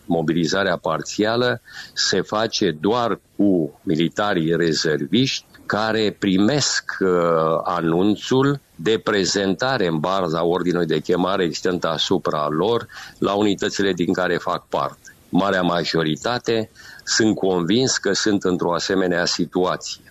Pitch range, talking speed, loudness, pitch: 85-105 Hz, 105 wpm, -20 LUFS, 95 Hz